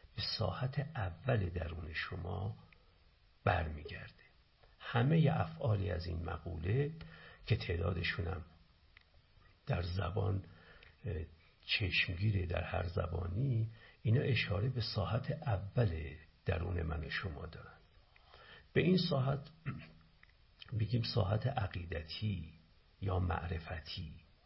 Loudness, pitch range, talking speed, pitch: -37 LUFS, 85-115 Hz, 90 wpm, 95 Hz